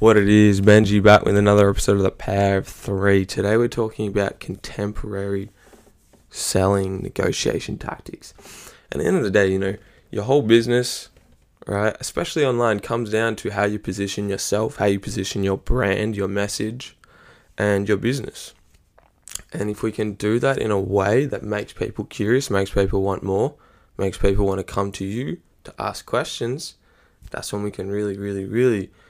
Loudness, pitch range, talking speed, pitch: -21 LUFS, 100-110 Hz, 175 wpm, 100 Hz